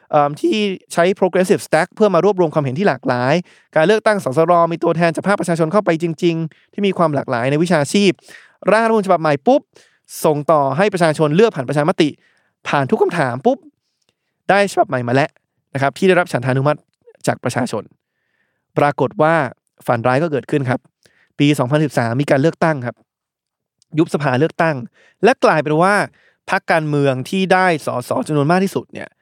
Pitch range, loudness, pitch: 145-185 Hz, -16 LUFS, 165 Hz